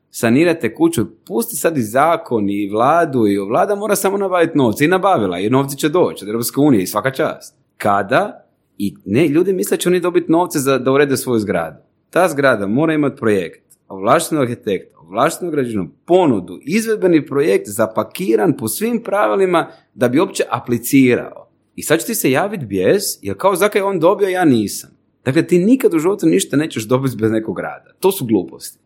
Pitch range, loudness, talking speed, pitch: 120-190 Hz, -16 LUFS, 185 wpm, 150 Hz